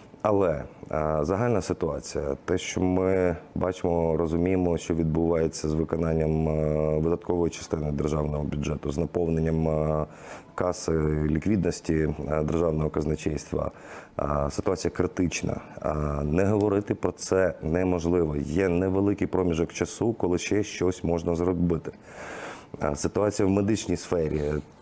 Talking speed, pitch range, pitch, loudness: 100 wpm, 75-90 Hz, 85 Hz, -27 LUFS